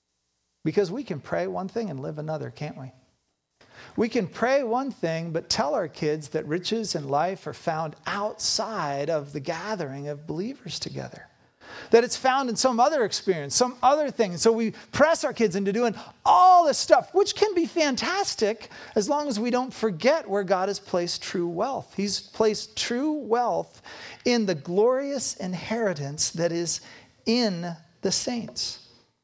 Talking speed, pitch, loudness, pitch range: 170 wpm, 210 Hz, -25 LUFS, 170-245 Hz